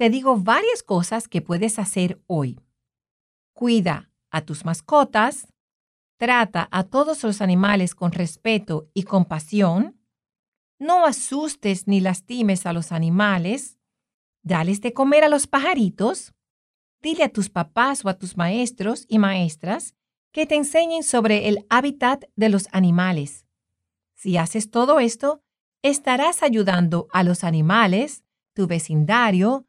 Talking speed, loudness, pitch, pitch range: 130 wpm, -21 LUFS, 210 Hz, 175-250 Hz